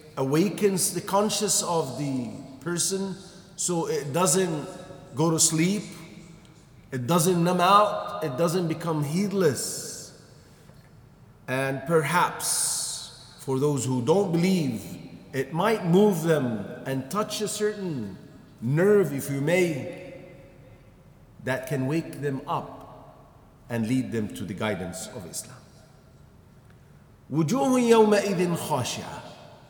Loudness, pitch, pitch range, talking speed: -25 LUFS, 165 Hz, 140-185 Hz, 105 wpm